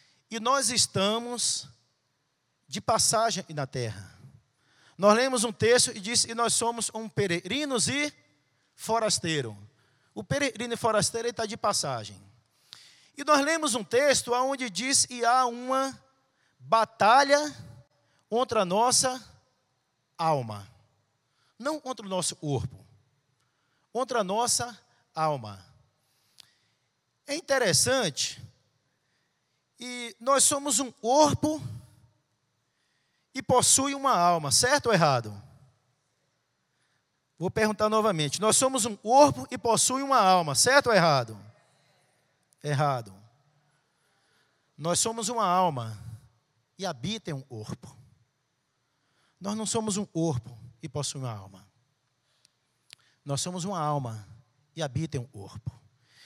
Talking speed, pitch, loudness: 110 wpm, 160 Hz, -26 LUFS